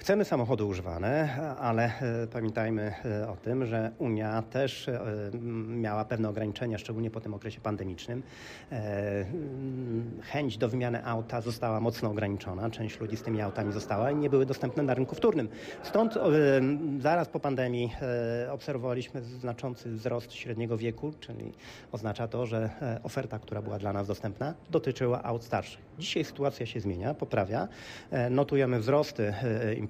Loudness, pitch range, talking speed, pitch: -32 LUFS, 110-130 Hz, 135 wpm, 120 Hz